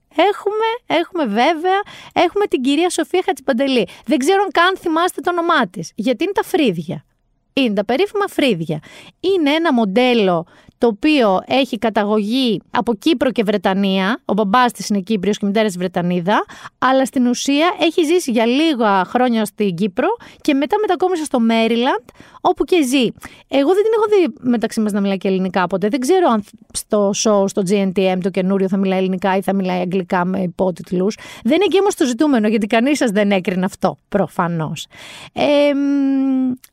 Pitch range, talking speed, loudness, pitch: 200-320 Hz, 175 wpm, -17 LUFS, 245 Hz